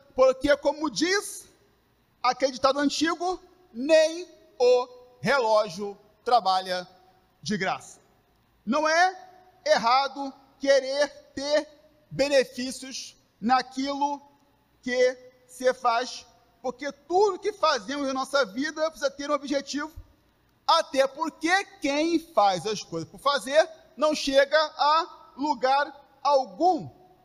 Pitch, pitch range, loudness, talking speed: 280 Hz, 250-310 Hz, -25 LUFS, 100 wpm